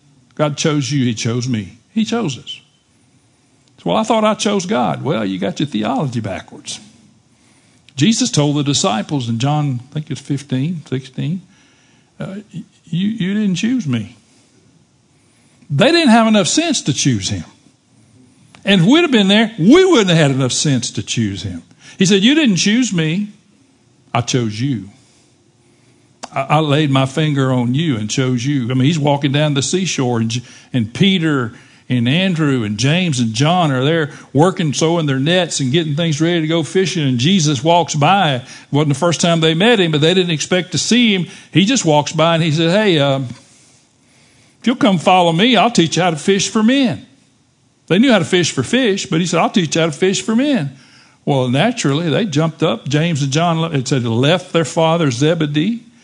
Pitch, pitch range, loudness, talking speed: 155 Hz, 130-185 Hz, -15 LUFS, 195 wpm